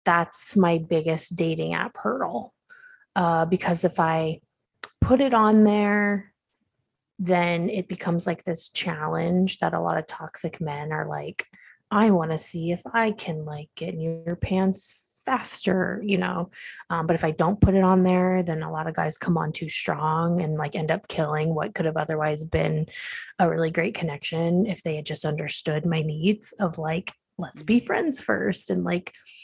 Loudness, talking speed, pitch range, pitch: -25 LUFS, 185 wpm, 160-190 Hz, 170 Hz